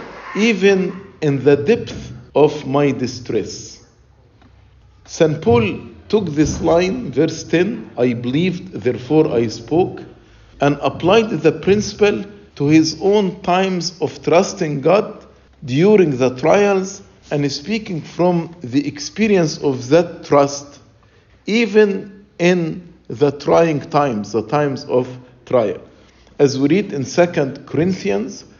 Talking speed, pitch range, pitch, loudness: 120 wpm, 130-180 Hz, 150 Hz, -17 LUFS